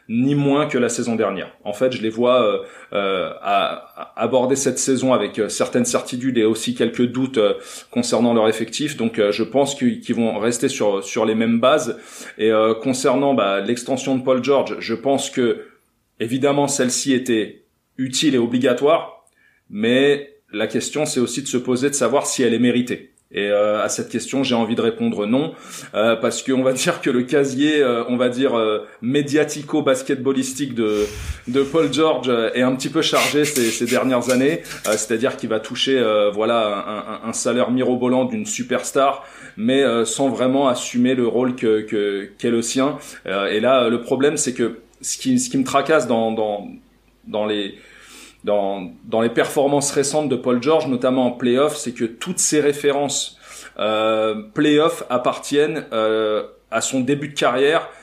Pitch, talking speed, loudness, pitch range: 125 Hz, 180 wpm, -19 LUFS, 115-140 Hz